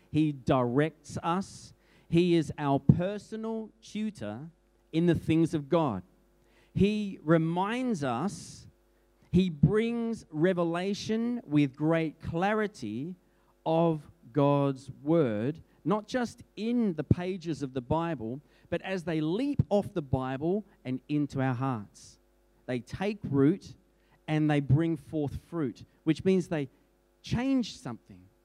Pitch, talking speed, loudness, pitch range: 160 Hz, 120 wpm, -30 LUFS, 140-190 Hz